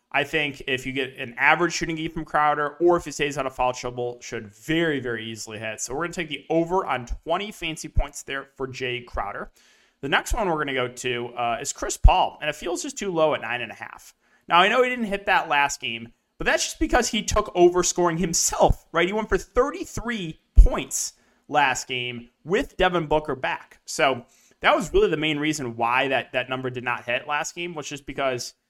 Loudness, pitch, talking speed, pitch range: -24 LUFS, 150 Hz, 230 wpm, 125-175 Hz